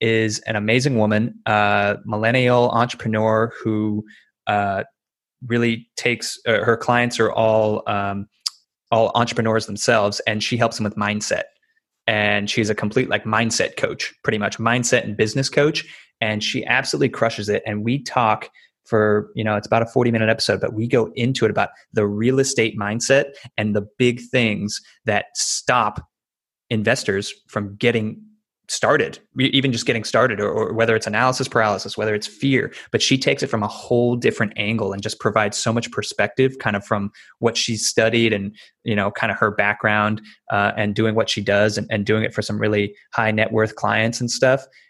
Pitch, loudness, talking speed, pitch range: 110 Hz, -20 LUFS, 185 wpm, 105-120 Hz